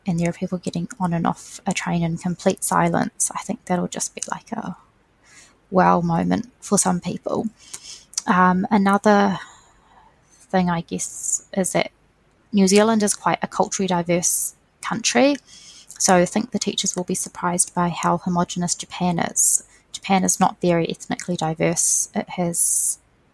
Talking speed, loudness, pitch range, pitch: 155 wpm, -21 LUFS, 175-200 Hz, 185 Hz